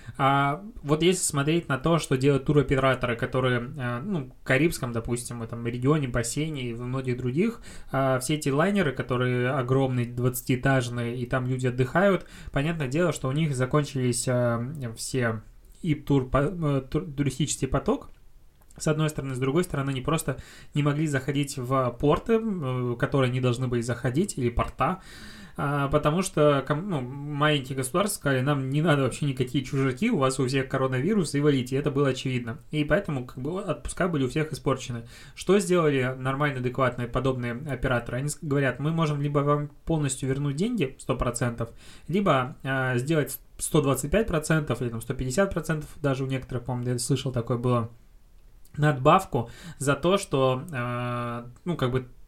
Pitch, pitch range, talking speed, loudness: 135 Hz, 125-150 Hz, 155 wpm, -26 LUFS